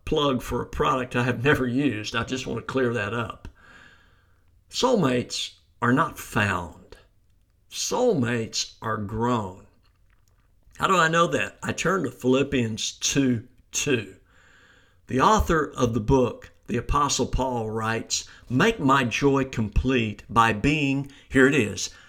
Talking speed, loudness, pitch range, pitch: 140 wpm, -24 LUFS, 105-130 Hz, 120 Hz